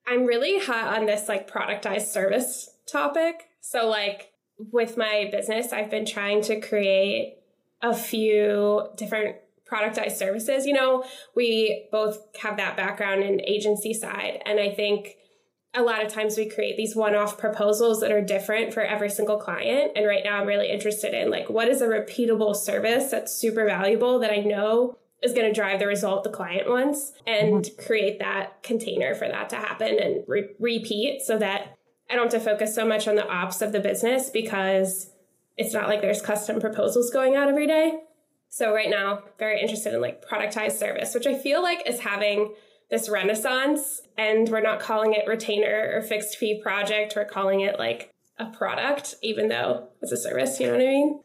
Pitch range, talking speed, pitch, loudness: 205-235 Hz, 190 wpm, 215 Hz, -25 LUFS